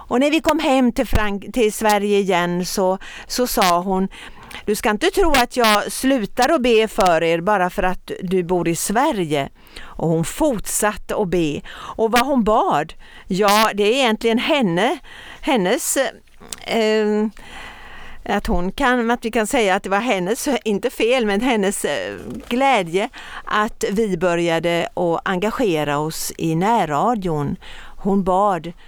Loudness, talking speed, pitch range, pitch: -19 LUFS, 155 wpm, 185-240 Hz, 210 Hz